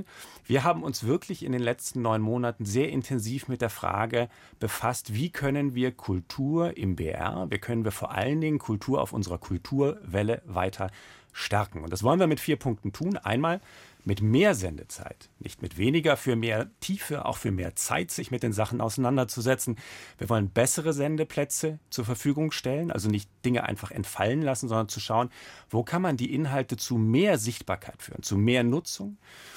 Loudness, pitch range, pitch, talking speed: -28 LUFS, 105-140 Hz, 120 Hz, 180 wpm